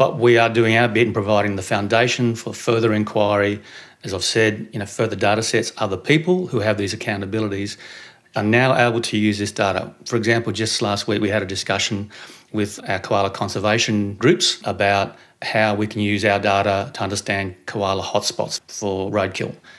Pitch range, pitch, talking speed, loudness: 100-115 Hz, 105 Hz, 190 wpm, -20 LUFS